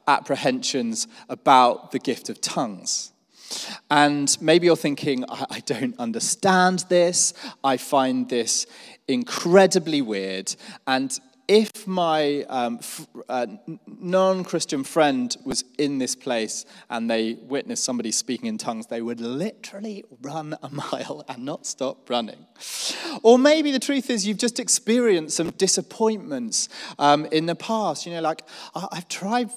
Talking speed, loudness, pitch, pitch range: 140 wpm, -23 LUFS, 170 Hz, 135-220 Hz